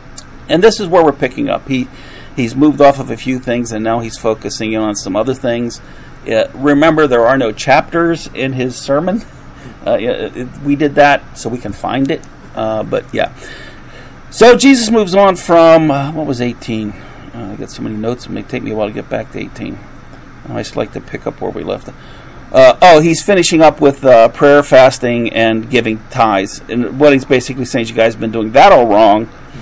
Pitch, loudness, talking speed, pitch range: 130 Hz, -11 LUFS, 215 wpm, 115-150 Hz